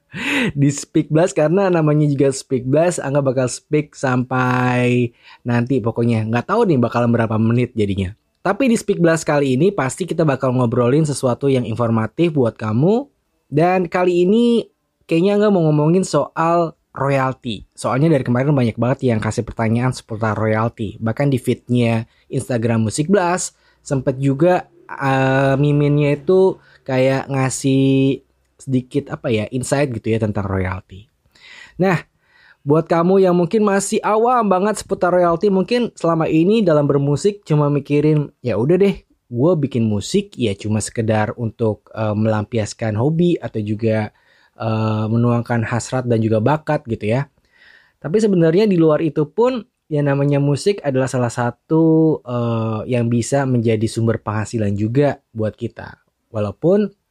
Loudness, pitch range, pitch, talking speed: -18 LUFS, 115-165 Hz, 135 Hz, 145 wpm